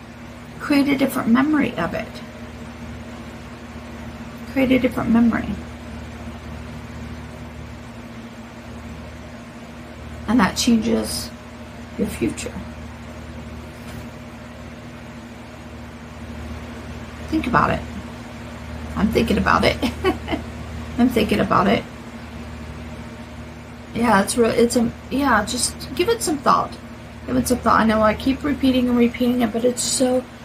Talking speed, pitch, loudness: 100 wpm, 215 Hz, -20 LUFS